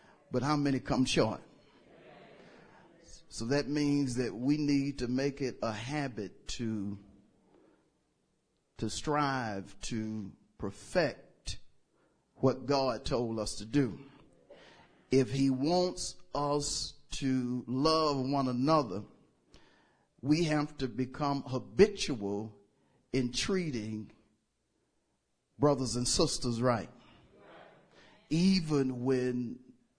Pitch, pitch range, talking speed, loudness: 130 Hz, 120-145 Hz, 95 wpm, -32 LUFS